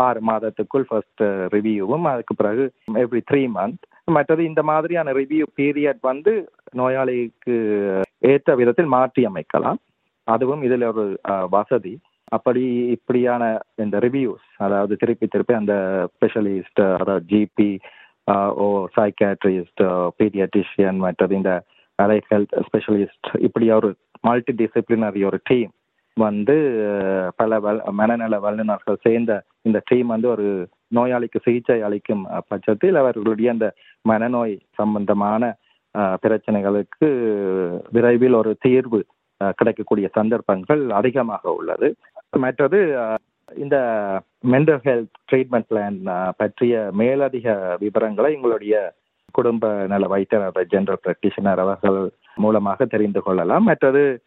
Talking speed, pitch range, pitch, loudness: 105 wpm, 100-125 Hz, 110 Hz, -20 LUFS